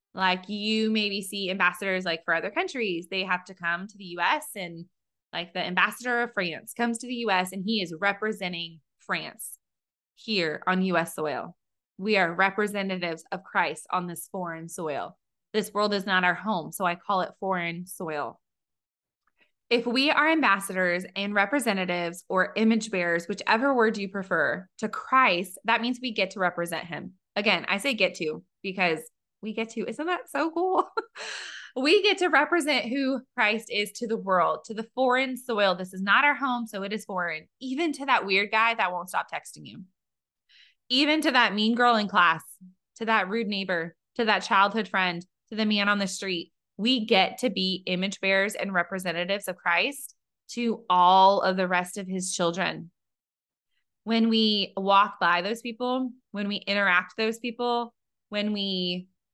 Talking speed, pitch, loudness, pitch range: 180 wpm, 200 Hz, -26 LUFS, 180-225 Hz